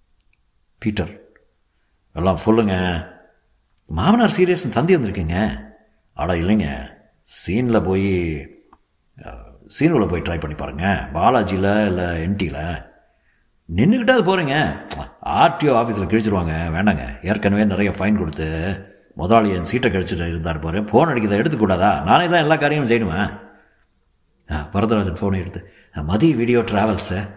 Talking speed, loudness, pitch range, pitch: 110 wpm, -19 LUFS, 85-115 Hz, 100 Hz